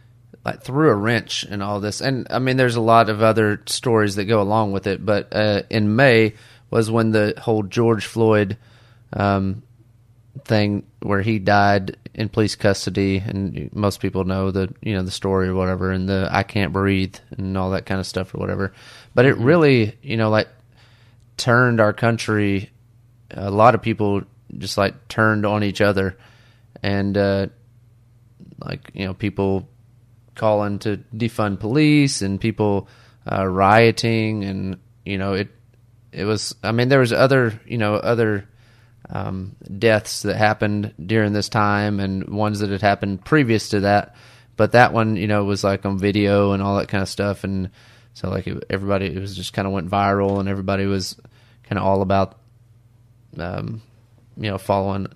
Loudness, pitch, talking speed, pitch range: -20 LUFS, 105 Hz, 175 wpm, 100-115 Hz